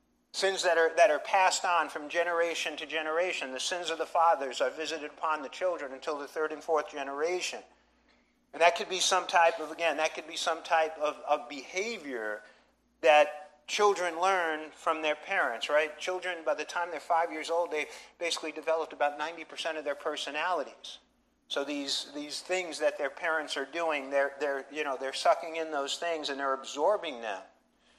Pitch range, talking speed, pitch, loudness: 150-170 Hz, 190 wpm, 160 Hz, -30 LUFS